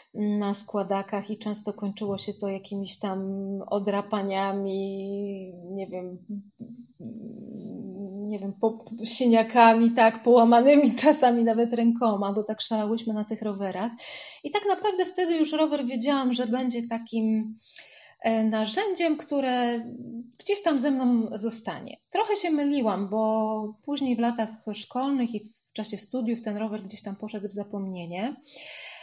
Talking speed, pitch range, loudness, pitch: 130 wpm, 205-245 Hz, -26 LUFS, 225 Hz